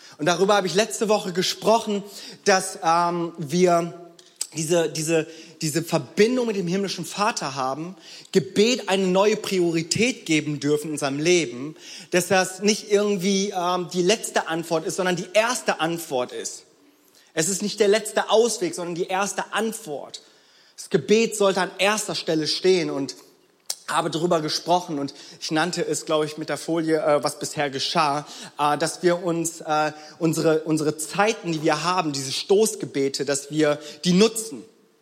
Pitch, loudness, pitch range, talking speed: 175 Hz, -23 LUFS, 155-200 Hz, 155 wpm